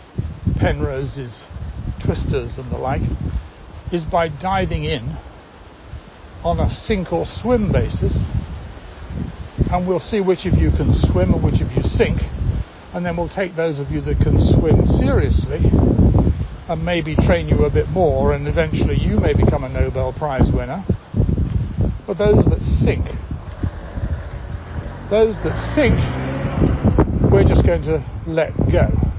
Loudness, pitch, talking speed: -19 LUFS, 100 Hz, 140 wpm